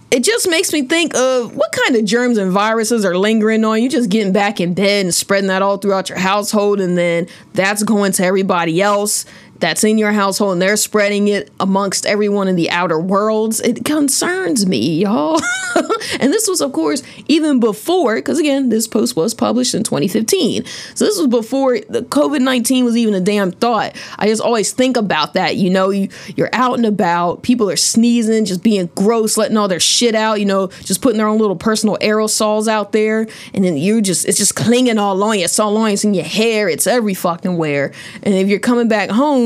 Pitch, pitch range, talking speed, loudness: 215 Hz, 195-240 Hz, 215 wpm, -15 LUFS